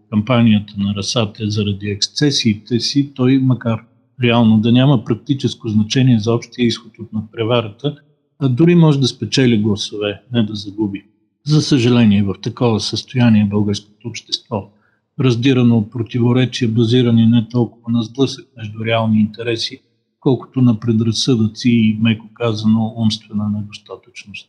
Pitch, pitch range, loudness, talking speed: 115 Hz, 110-125 Hz, -16 LUFS, 130 wpm